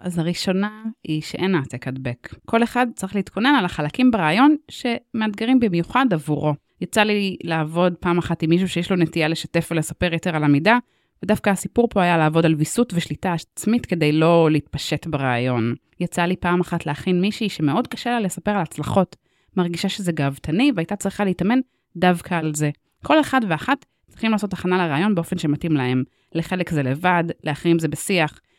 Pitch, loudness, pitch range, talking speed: 175 Hz, -21 LUFS, 160-205 Hz, 170 wpm